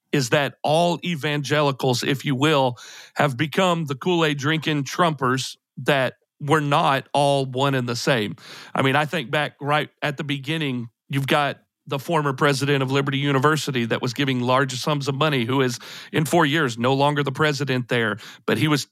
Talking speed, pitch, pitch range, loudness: 185 wpm, 145 Hz, 130-150 Hz, -22 LUFS